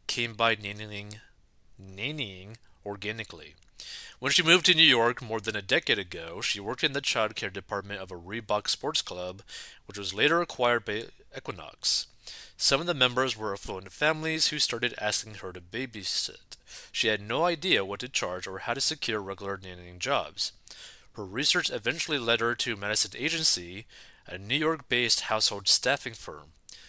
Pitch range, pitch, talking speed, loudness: 100-130 Hz, 110 Hz, 170 wpm, -27 LUFS